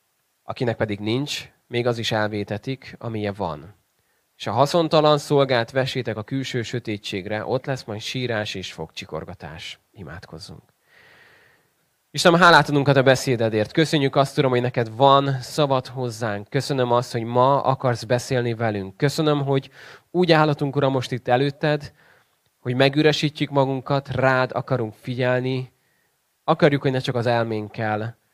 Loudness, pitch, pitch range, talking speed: -21 LUFS, 130 Hz, 115-140 Hz, 135 wpm